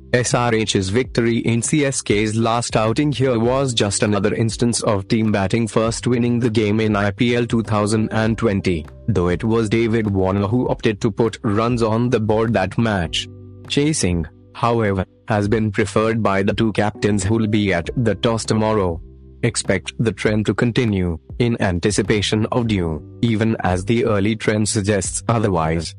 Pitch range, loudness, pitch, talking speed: 100-115 Hz, -19 LUFS, 110 Hz, 155 wpm